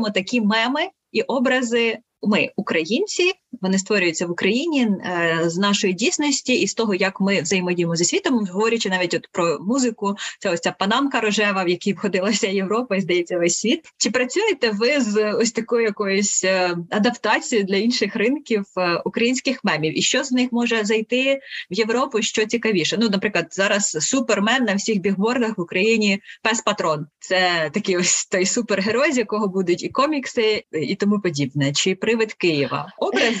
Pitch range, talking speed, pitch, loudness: 190-235 Hz, 165 wpm, 215 Hz, -20 LUFS